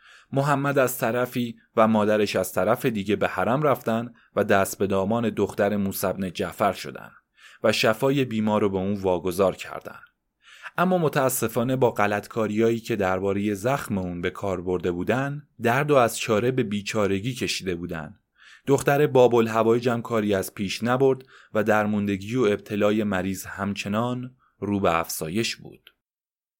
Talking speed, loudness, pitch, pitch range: 145 wpm, -24 LUFS, 110 Hz, 100-125 Hz